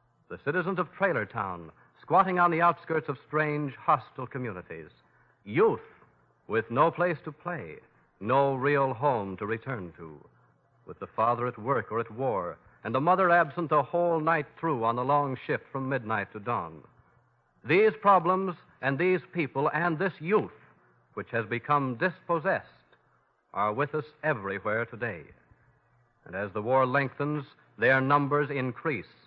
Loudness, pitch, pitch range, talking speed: -28 LUFS, 145 Hz, 120-165 Hz, 150 wpm